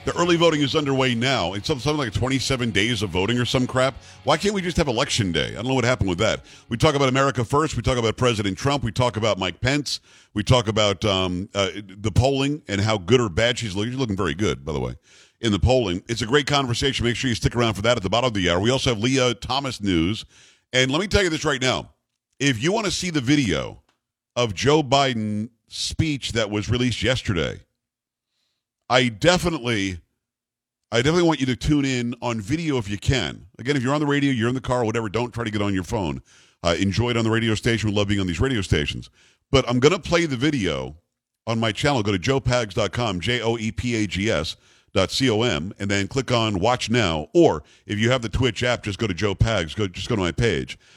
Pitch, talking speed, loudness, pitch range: 120 Hz, 235 wpm, -22 LUFS, 105-135 Hz